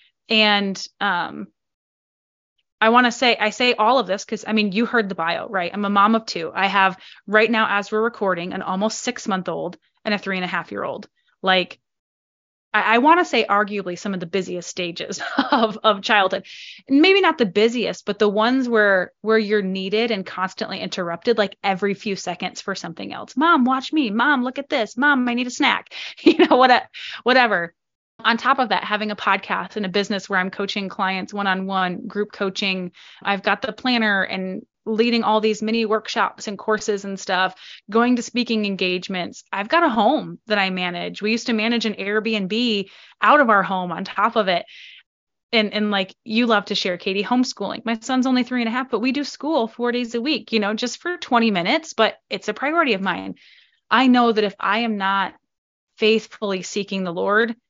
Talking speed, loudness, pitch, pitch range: 210 wpm, -20 LUFS, 215 Hz, 195-240 Hz